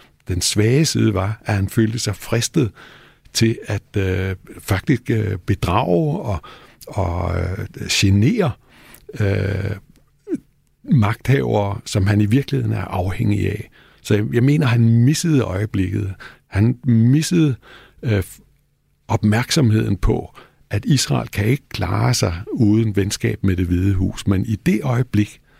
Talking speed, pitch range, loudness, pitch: 125 wpm, 100-120 Hz, -19 LUFS, 105 Hz